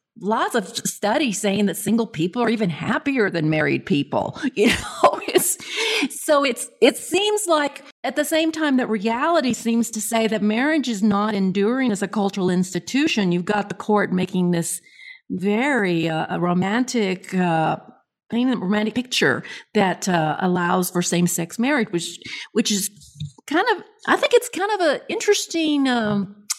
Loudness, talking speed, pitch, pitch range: -21 LUFS, 160 wpm, 220 Hz, 185-285 Hz